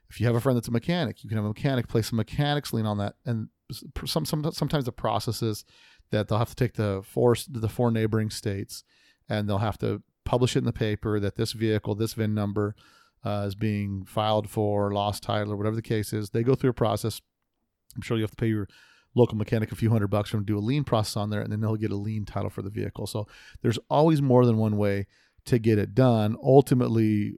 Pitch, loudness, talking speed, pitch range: 110 Hz, -27 LUFS, 245 wpm, 105-120 Hz